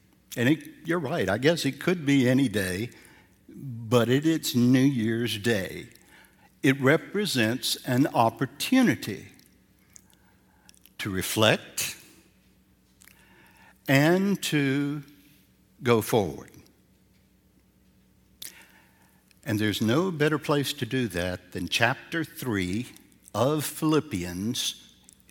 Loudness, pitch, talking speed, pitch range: -26 LUFS, 130 Hz, 95 wpm, 110-150 Hz